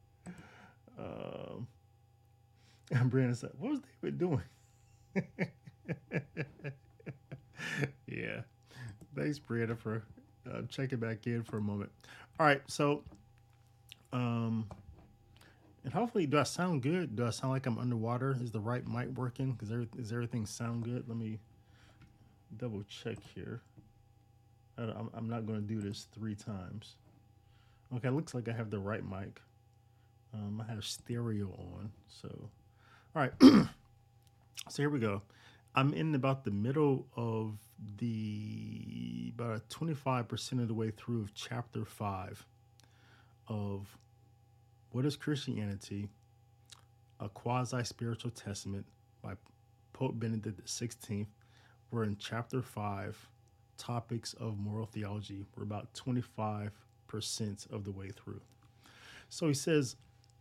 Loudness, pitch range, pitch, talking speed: -37 LUFS, 110-125 Hz, 115 Hz, 125 wpm